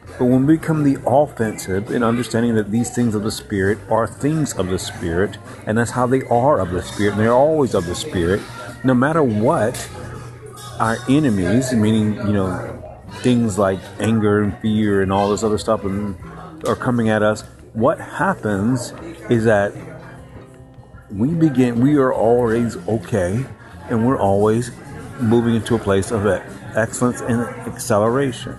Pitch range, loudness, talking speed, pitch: 105-125 Hz, -18 LUFS, 155 wpm, 115 Hz